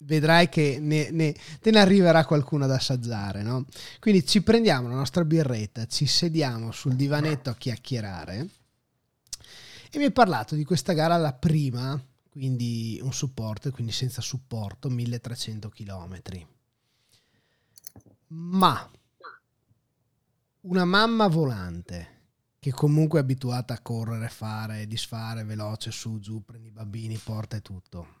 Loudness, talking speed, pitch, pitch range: -25 LUFS, 130 wpm, 125 Hz, 115-150 Hz